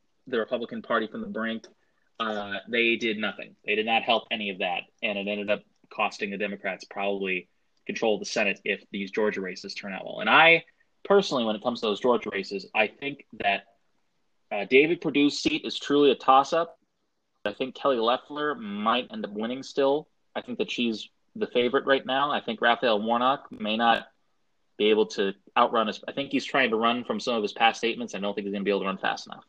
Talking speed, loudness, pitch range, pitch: 225 wpm, -26 LUFS, 105-140 Hz, 115 Hz